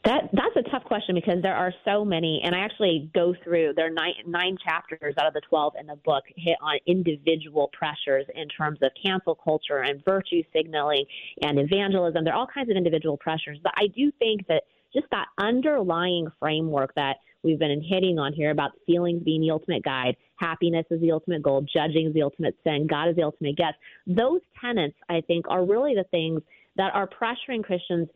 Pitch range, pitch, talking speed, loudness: 155-185 Hz, 165 Hz, 205 wpm, -25 LUFS